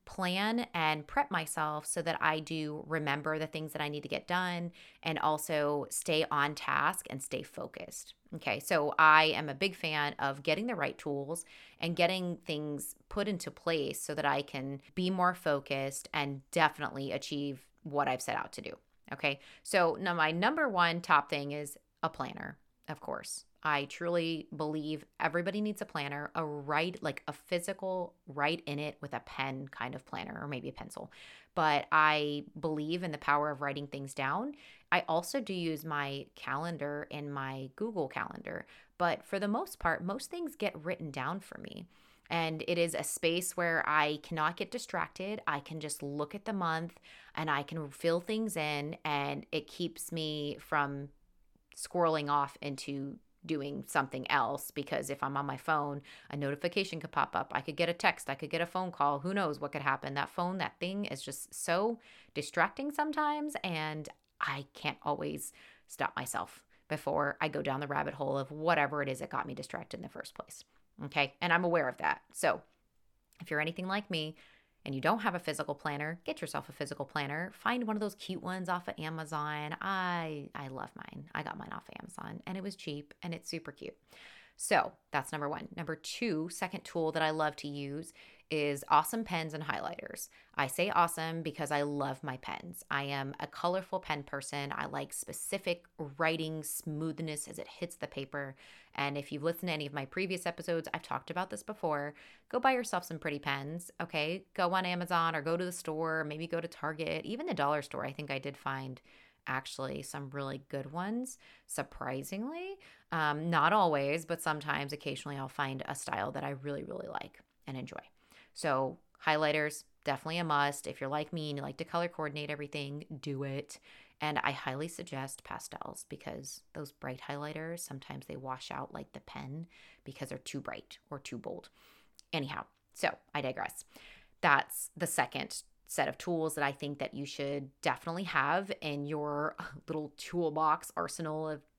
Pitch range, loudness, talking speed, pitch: 145-170 Hz, -35 LUFS, 190 wpm, 155 Hz